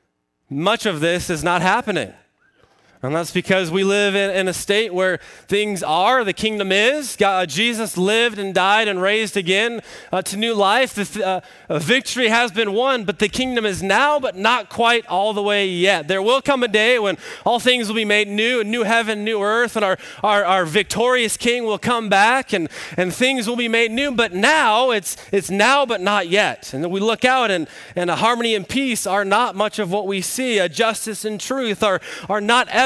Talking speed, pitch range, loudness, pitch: 215 wpm, 195-235 Hz, -18 LUFS, 210 Hz